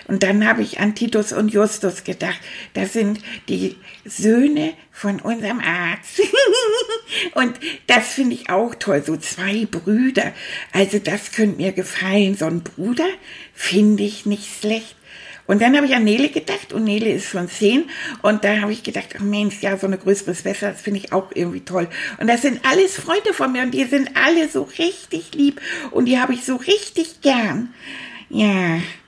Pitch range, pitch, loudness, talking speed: 200-275 Hz, 215 Hz, -19 LUFS, 185 wpm